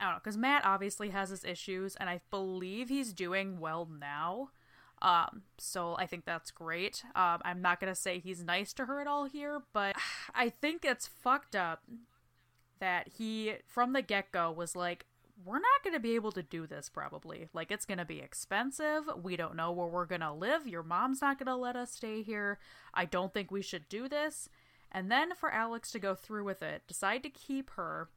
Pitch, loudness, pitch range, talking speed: 200 Hz, -36 LUFS, 180-255 Hz, 215 wpm